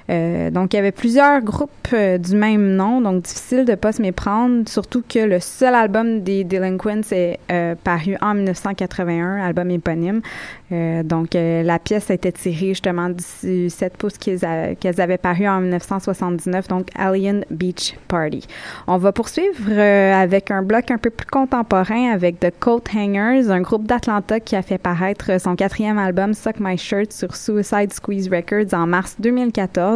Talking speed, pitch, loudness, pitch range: 175 wpm, 195 Hz, -18 LUFS, 180-215 Hz